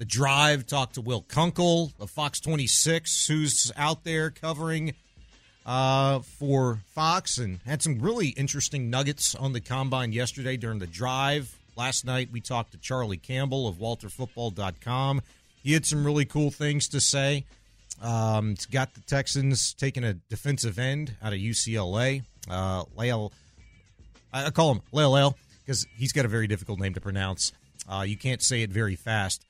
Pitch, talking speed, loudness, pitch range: 125 Hz, 160 wpm, -27 LUFS, 110-140 Hz